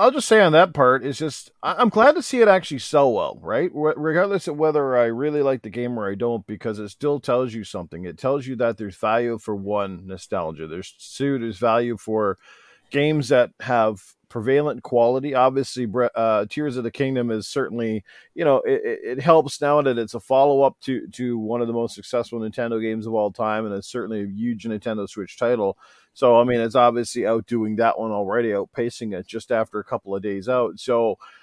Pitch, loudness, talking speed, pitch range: 120 Hz, -22 LUFS, 210 wpm, 110-140 Hz